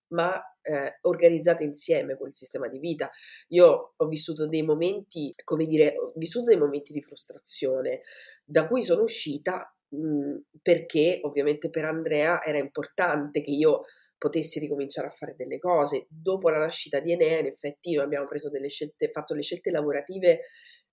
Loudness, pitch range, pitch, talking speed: -27 LUFS, 150-185 Hz, 155 Hz, 160 wpm